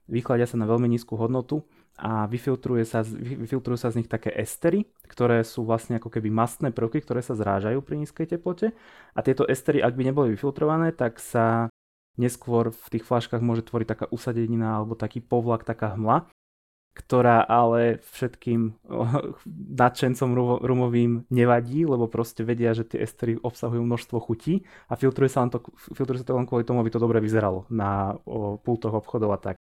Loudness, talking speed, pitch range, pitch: -25 LUFS, 170 wpm, 115-125 Hz, 120 Hz